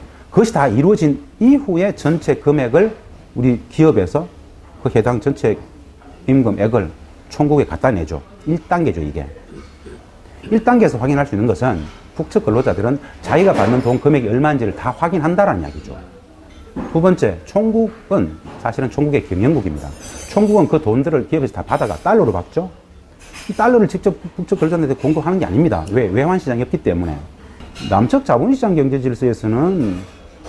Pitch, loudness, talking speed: 135 Hz, -16 LUFS, 340 characters per minute